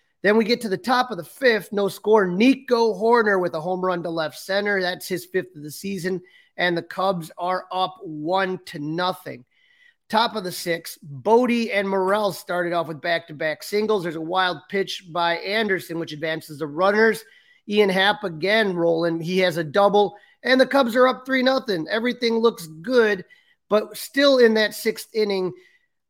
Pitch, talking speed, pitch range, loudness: 195 Hz, 190 wpm, 175-230 Hz, -22 LUFS